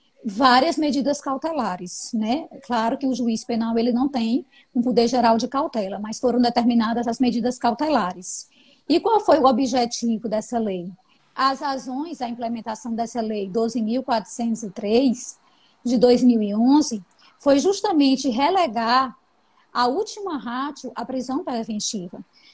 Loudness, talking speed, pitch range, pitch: -22 LUFS, 130 wpm, 230-275 Hz, 245 Hz